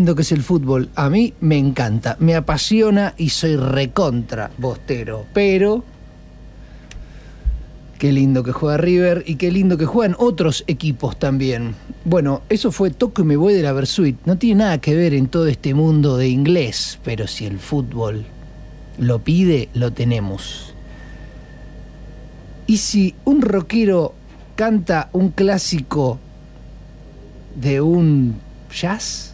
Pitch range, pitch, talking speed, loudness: 130-180 Hz, 150 Hz, 135 wpm, -17 LUFS